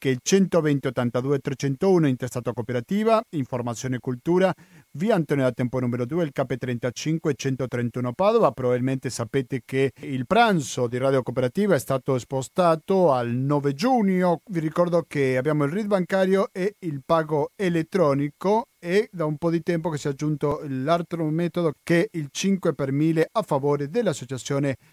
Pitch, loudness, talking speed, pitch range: 150 Hz, -24 LUFS, 160 wpm, 130-175 Hz